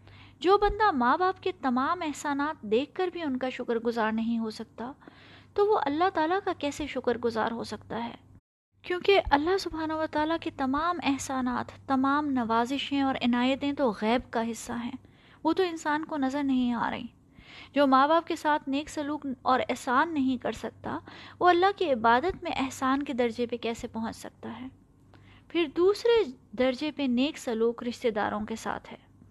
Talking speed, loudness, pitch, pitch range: 180 wpm, -28 LUFS, 270 Hz, 240-320 Hz